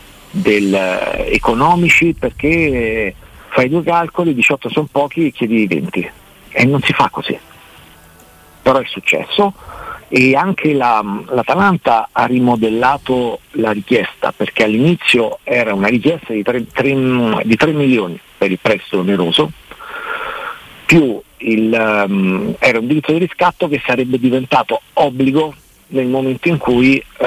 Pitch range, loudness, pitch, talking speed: 115-155 Hz, -14 LUFS, 130 Hz, 135 wpm